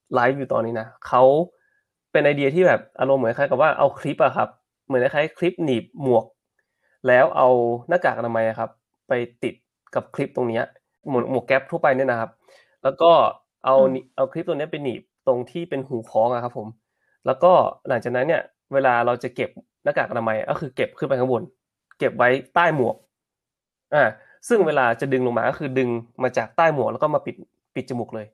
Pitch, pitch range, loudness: 130 Hz, 120-140 Hz, -21 LUFS